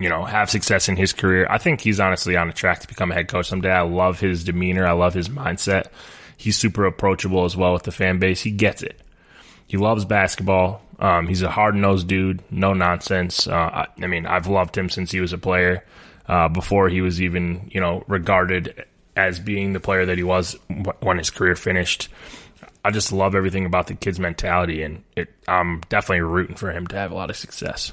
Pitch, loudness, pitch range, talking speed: 95 Hz, -20 LUFS, 90-95 Hz, 225 wpm